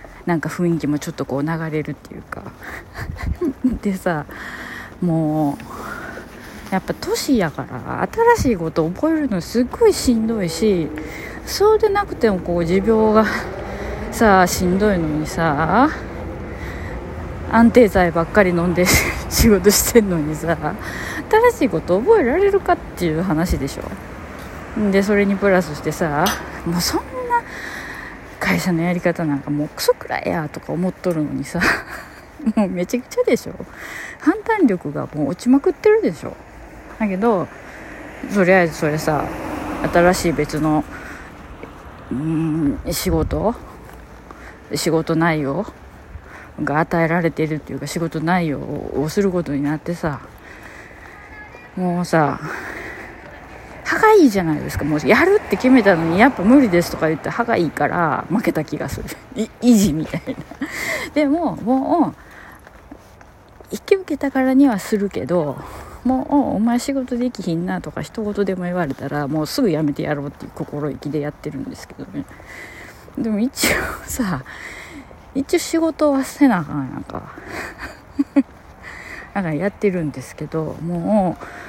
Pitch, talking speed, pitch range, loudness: 180 Hz, 285 characters per minute, 155-245 Hz, -19 LUFS